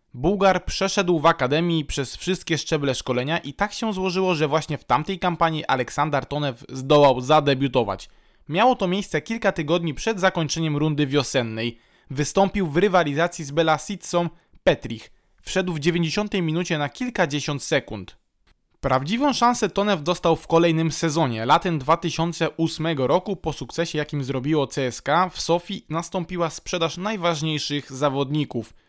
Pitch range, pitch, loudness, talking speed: 145-180 Hz, 165 Hz, -22 LUFS, 135 wpm